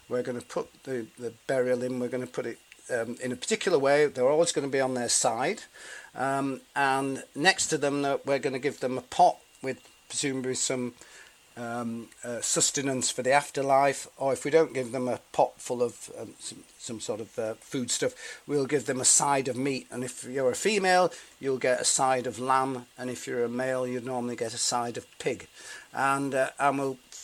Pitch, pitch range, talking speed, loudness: 130 Hz, 125-140 Hz, 220 wpm, -28 LUFS